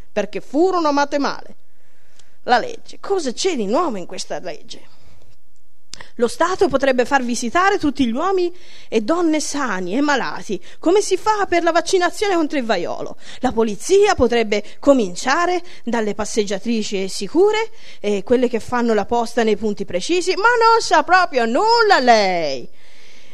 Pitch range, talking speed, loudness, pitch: 230-360 Hz, 145 wpm, -18 LUFS, 280 Hz